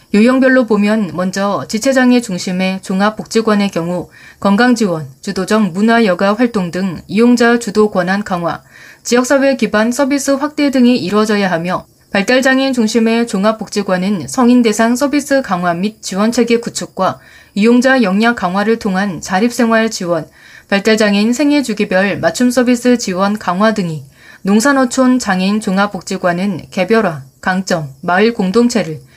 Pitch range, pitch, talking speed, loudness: 185-240 Hz, 210 Hz, 325 characters per minute, -13 LUFS